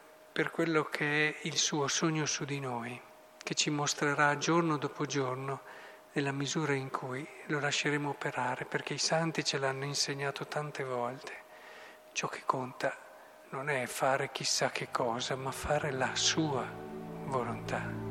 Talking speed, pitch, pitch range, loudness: 150 wpm, 145 Hz, 135-150 Hz, -33 LUFS